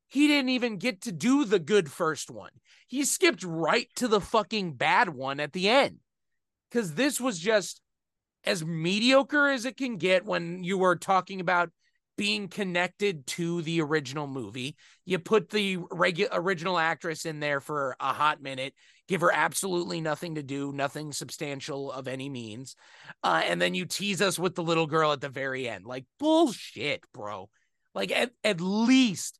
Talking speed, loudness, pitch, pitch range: 175 wpm, -27 LUFS, 180 Hz, 150-215 Hz